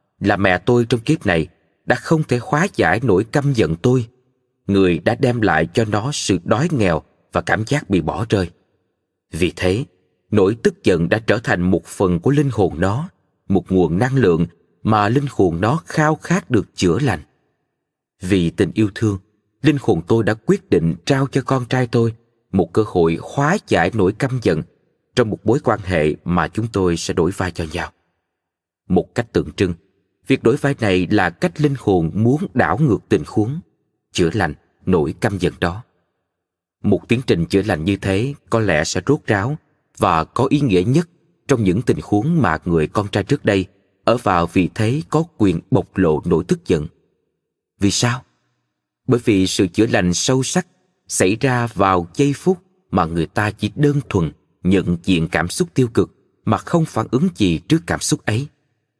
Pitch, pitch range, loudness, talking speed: 105 Hz, 90-135 Hz, -18 LUFS, 190 wpm